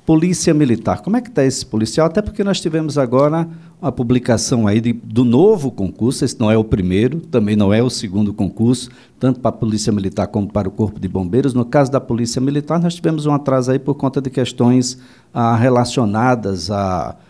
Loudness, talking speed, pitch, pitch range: -16 LUFS, 205 wpm, 125 Hz, 110-140 Hz